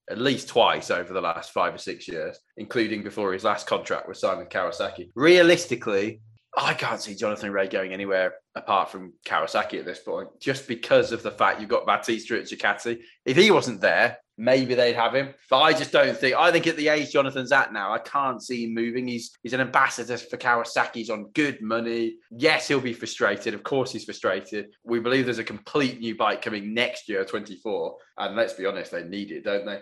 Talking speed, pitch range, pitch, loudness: 210 wpm, 115-170 Hz, 130 Hz, -24 LUFS